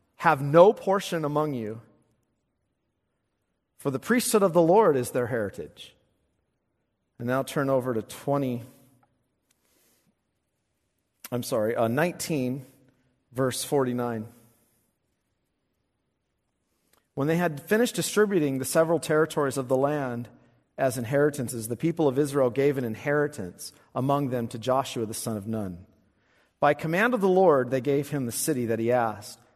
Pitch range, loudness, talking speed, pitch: 120-150 Hz, -25 LUFS, 140 wpm, 135 Hz